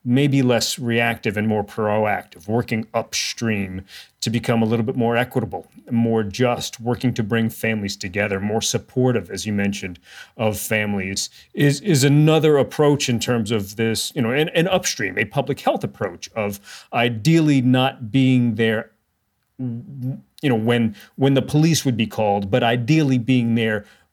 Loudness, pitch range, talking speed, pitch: -20 LUFS, 110-130 Hz, 160 wpm, 115 Hz